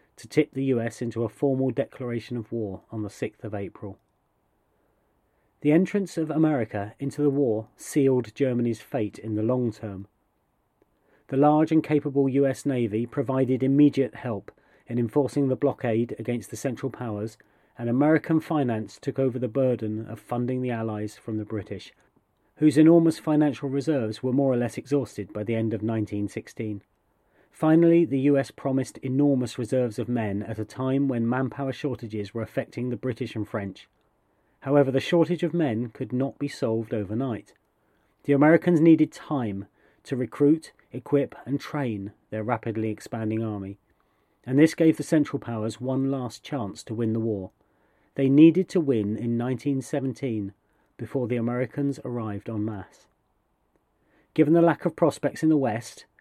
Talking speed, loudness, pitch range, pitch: 160 wpm, -25 LUFS, 110-140 Hz, 125 Hz